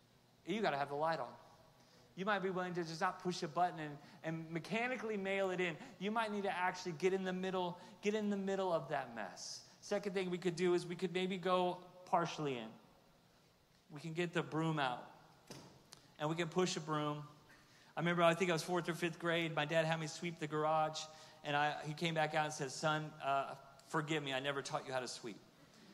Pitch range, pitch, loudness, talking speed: 155-185 Hz, 165 Hz, -39 LUFS, 230 wpm